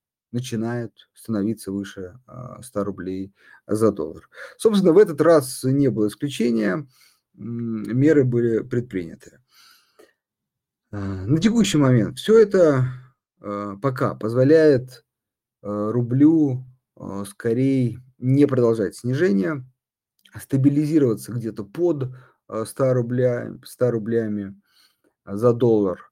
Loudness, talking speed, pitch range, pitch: -21 LUFS, 85 wpm, 110-135 Hz, 125 Hz